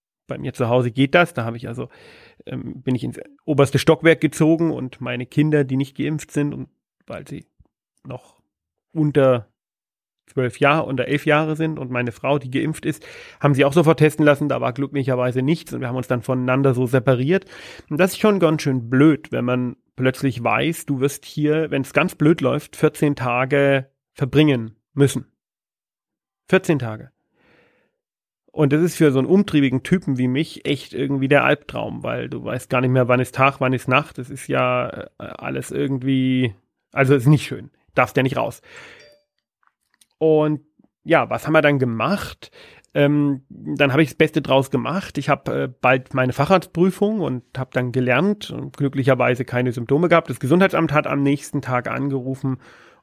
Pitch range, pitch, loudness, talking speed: 130-155 Hz, 140 Hz, -20 LUFS, 180 wpm